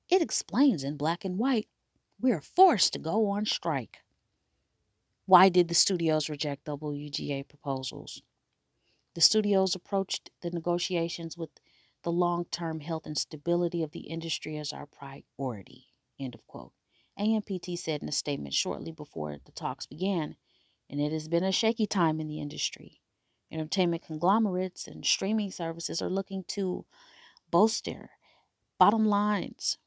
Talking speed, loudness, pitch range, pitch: 145 wpm, -29 LUFS, 150-195 Hz, 170 Hz